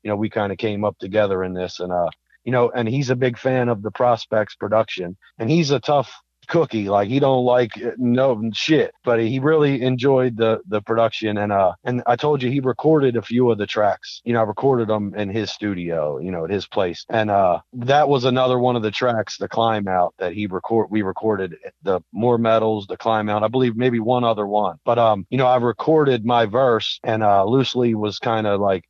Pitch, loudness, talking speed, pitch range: 115 Hz, -20 LUFS, 235 wpm, 105-125 Hz